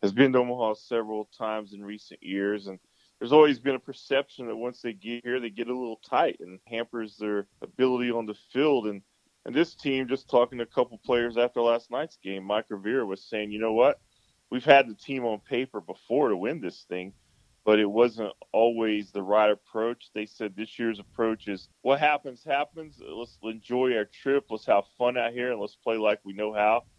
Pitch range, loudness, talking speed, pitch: 105-125 Hz, -27 LUFS, 215 wpm, 115 Hz